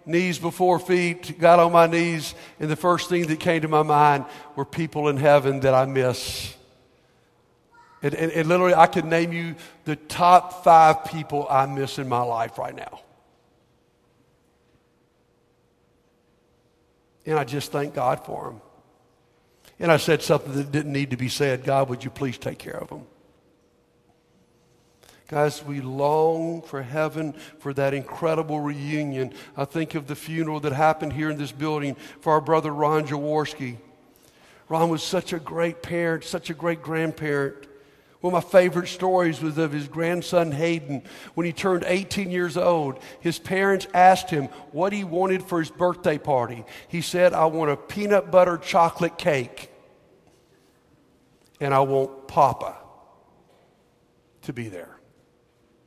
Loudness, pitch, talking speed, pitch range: -23 LUFS, 155 Hz, 155 wpm, 140-170 Hz